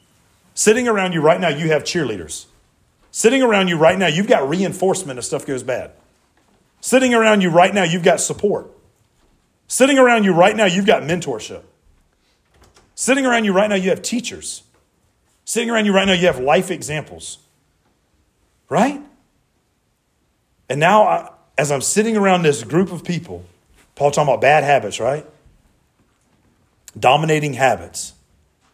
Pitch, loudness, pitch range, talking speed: 180 Hz, -16 LUFS, 135-210 Hz, 150 wpm